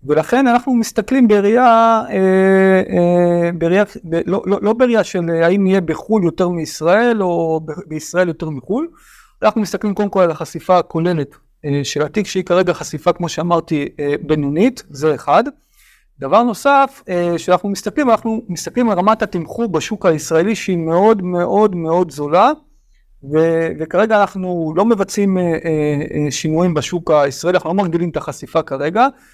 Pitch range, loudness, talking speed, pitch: 160-210 Hz, -16 LUFS, 150 wpm, 180 Hz